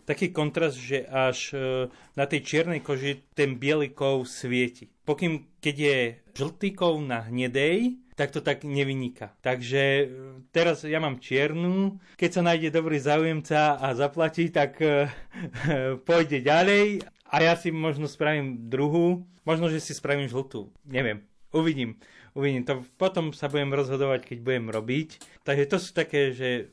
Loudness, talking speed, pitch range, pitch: -26 LUFS, 145 wpm, 130-160 Hz, 145 Hz